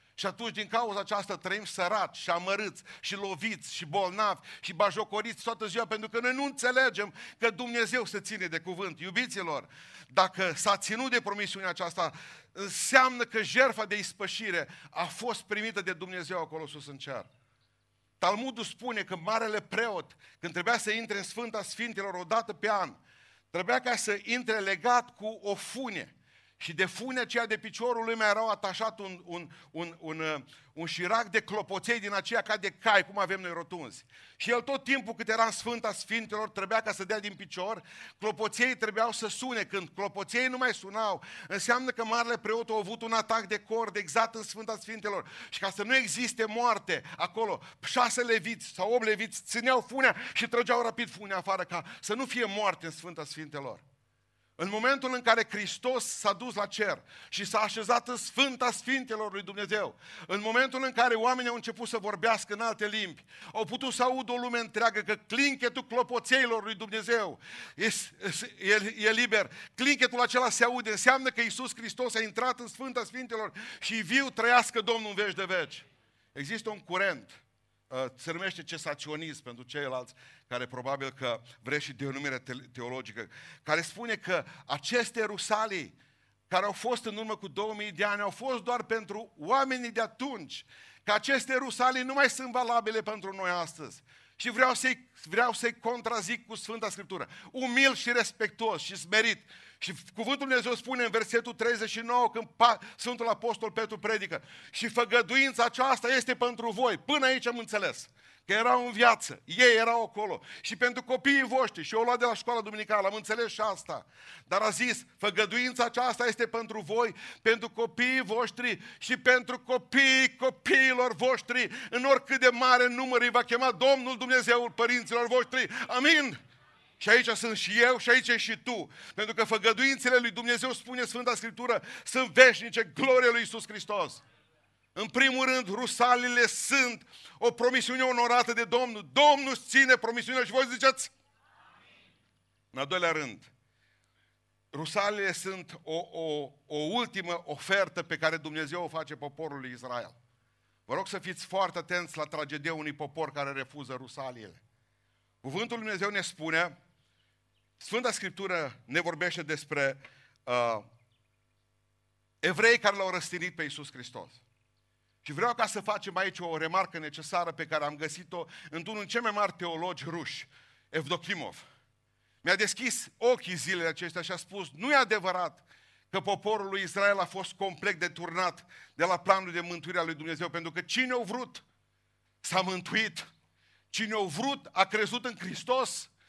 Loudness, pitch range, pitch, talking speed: -29 LUFS, 175-240 Hz, 215 Hz, 165 wpm